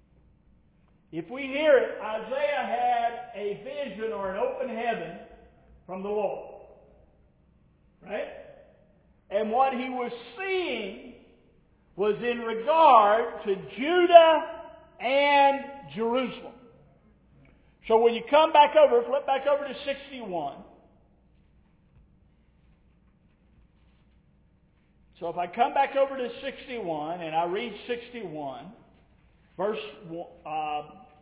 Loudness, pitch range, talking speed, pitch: -25 LUFS, 195-280 Hz, 100 wpm, 240 Hz